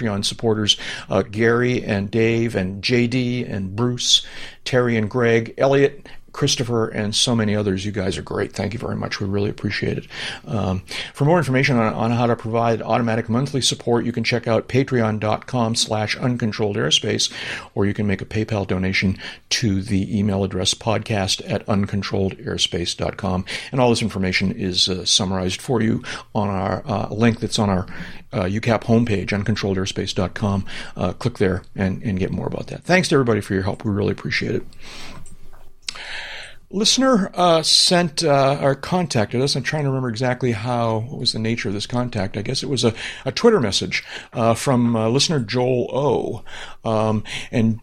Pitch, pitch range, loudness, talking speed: 115 Hz, 100-125 Hz, -20 LUFS, 180 wpm